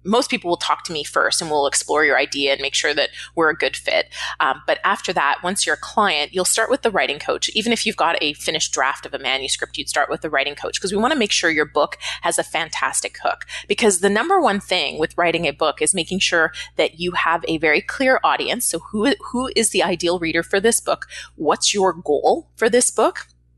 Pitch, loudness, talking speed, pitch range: 180 Hz, -19 LUFS, 245 wpm, 155-220 Hz